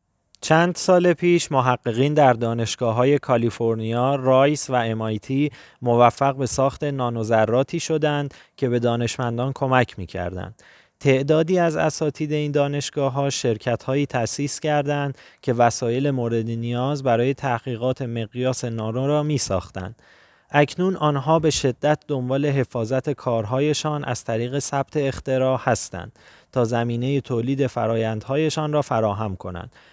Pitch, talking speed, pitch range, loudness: 130 Hz, 120 wpm, 115-145 Hz, -22 LUFS